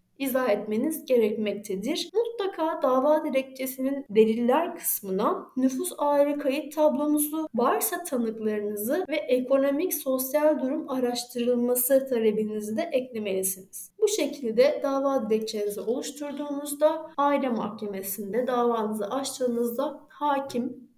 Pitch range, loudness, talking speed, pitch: 225-290 Hz, -26 LUFS, 90 wpm, 260 Hz